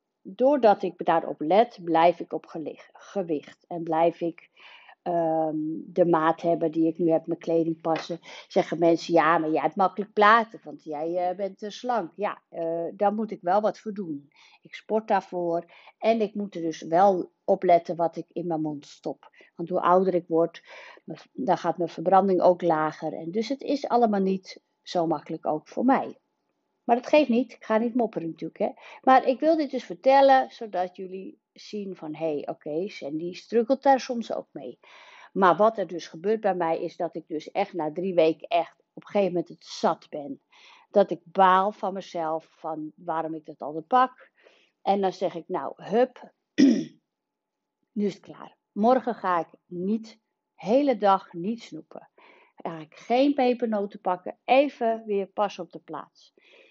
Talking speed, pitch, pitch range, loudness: 190 wpm, 185 Hz, 165-225 Hz, -25 LUFS